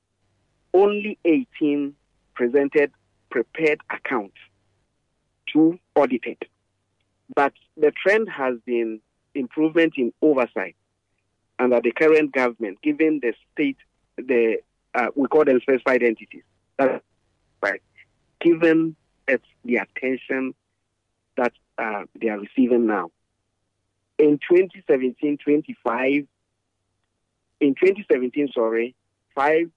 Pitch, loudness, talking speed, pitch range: 130 Hz, -22 LUFS, 95 wpm, 105-155 Hz